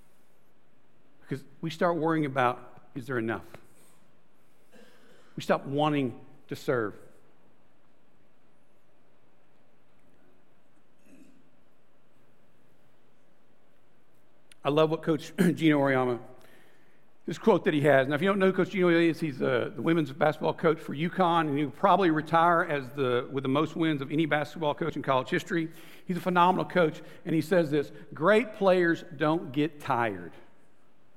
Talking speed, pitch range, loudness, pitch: 140 wpm, 135-170 Hz, -27 LUFS, 155 Hz